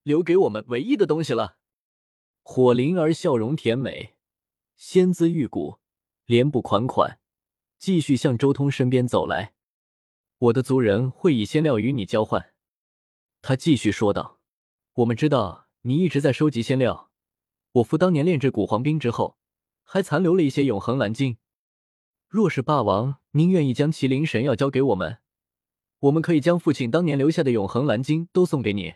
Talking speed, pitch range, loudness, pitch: 250 characters per minute, 115-155 Hz, -22 LUFS, 130 Hz